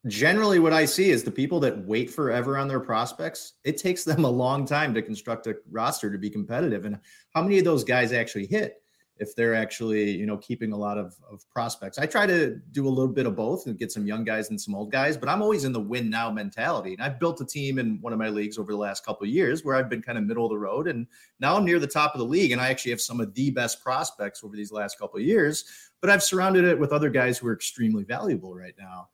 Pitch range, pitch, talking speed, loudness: 105-145 Hz, 120 Hz, 275 wpm, -25 LUFS